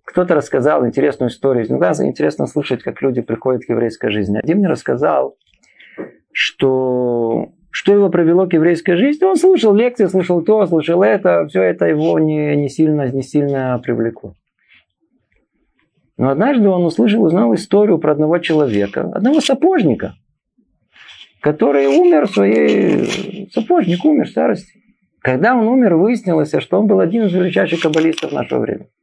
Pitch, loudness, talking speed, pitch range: 165 Hz, -15 LUFS, 150 wpm, 130-210 Hz